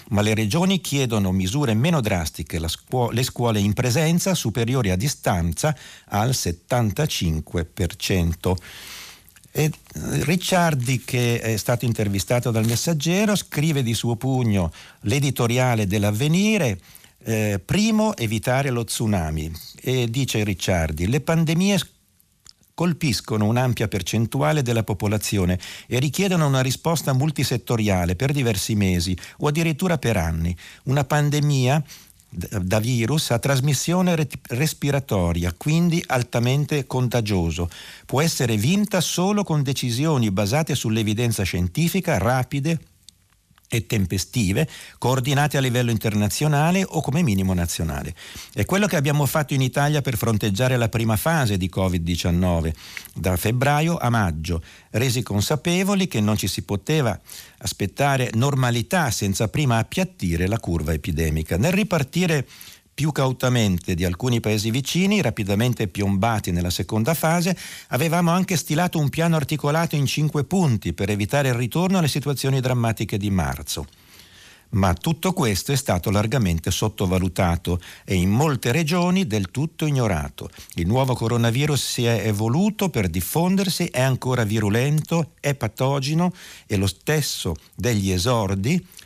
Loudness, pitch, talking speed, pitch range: -22 LUFS, 120 Hz, 125 wpm, 100-150 Hz